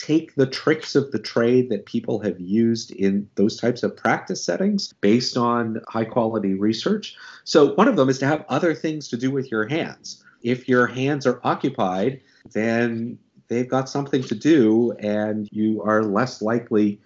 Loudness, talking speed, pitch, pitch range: -22 LUFS, 180 wpm, 120 Hz, 110-130 Hz